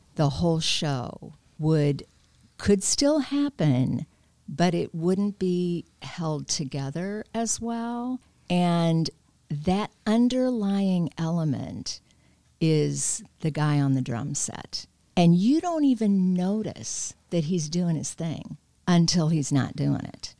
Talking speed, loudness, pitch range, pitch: 120 wpm, -26 LUFS, 145-200 Hz, 170 Hz